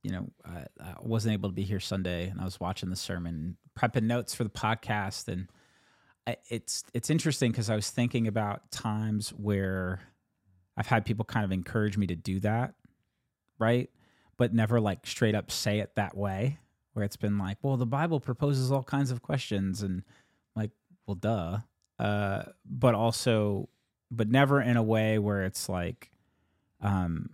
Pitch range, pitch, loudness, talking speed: 100-120 Hz, 110 Hz, -30 LUFS, 175 wpm